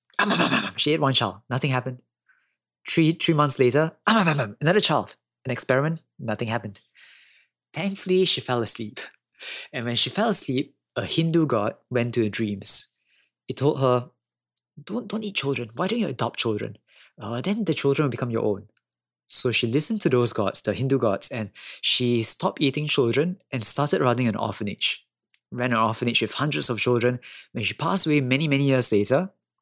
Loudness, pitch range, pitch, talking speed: -23 LUFS, 115-155 Hz, 130 Hz, 190 wpm